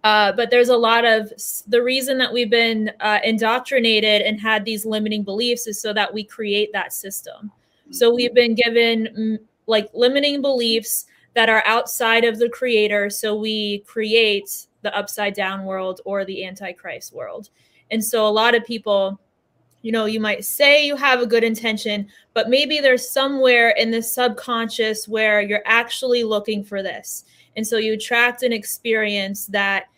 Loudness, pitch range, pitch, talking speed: -18 LUFS, 210-235 Hz, 220 Hz, 170 wpm